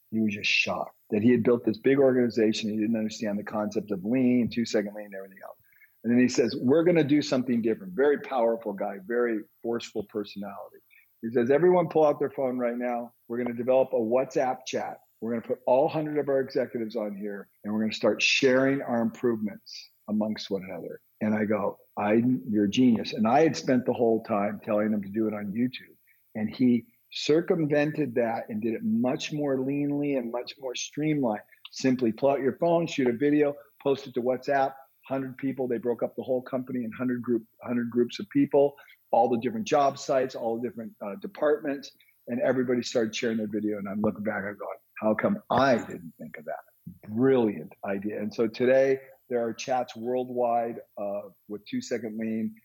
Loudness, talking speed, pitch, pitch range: -27 LUFS, 205 wpm, 120 Hz, 110-135 Hz